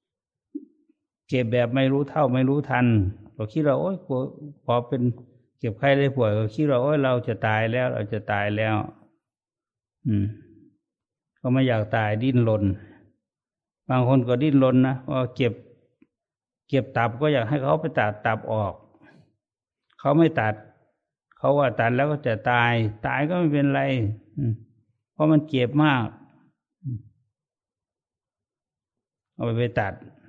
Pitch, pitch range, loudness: 125 Hz, 110-140 Hz, -23 LUFS